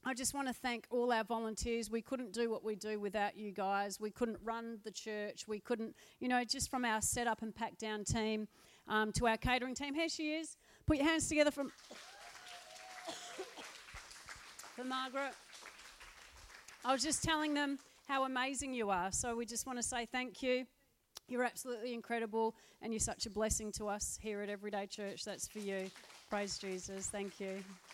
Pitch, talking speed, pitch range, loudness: 230 Hz, 190 wpm, 210-255 Hz, -39 LUFS